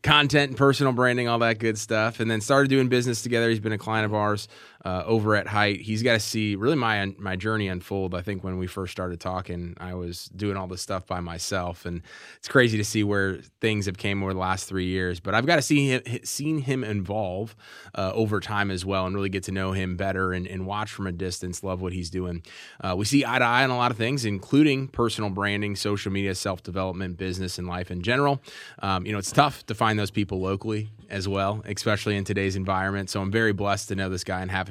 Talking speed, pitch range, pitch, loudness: 245 wpm, 95-110 Hz, 100 Hz, -25 LUFS